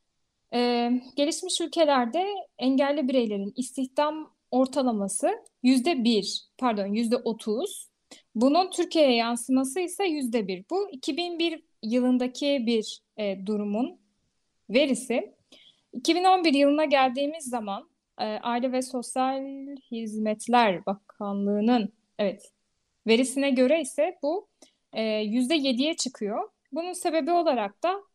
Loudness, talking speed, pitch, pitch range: -26 LUFS, 100 wpm, 260 Hz, 230-310 Hz